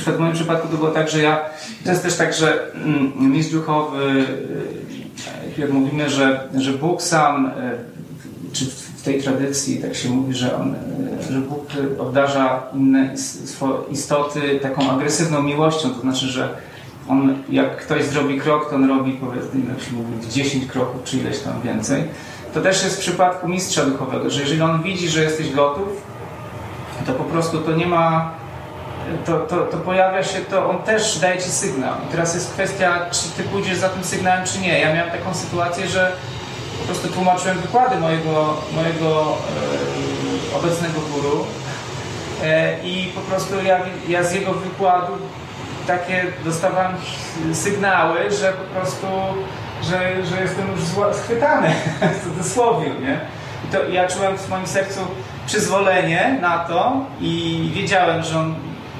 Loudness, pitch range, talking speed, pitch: -20 LUFS, 135-185 Hz, 150 wpm, 160 Hz